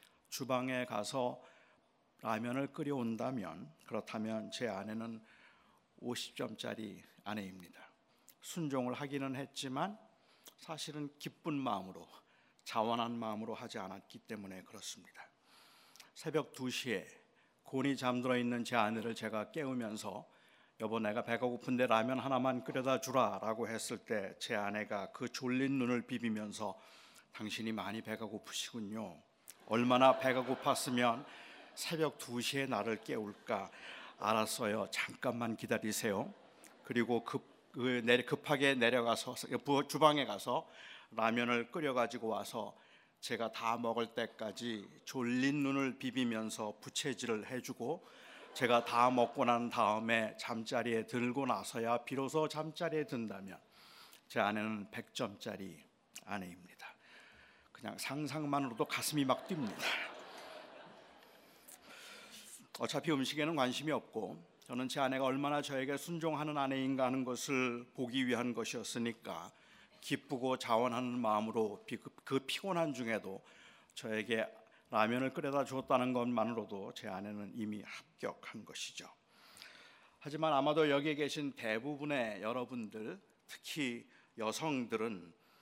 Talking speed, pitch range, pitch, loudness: 275 characters per minute, 110-135 Hz, 125 Hz, -38 LUFS